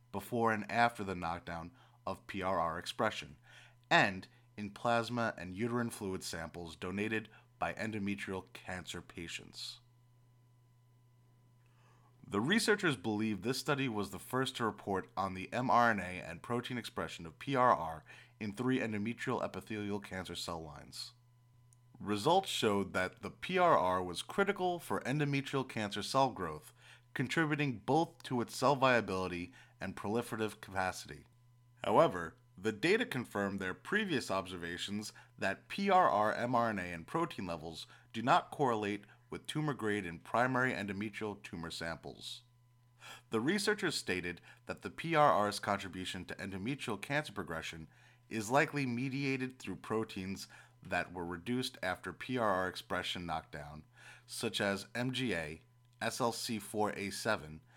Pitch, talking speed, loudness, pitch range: 115 Hz, 120 wpm, -36 LUFS, 95-125 Hz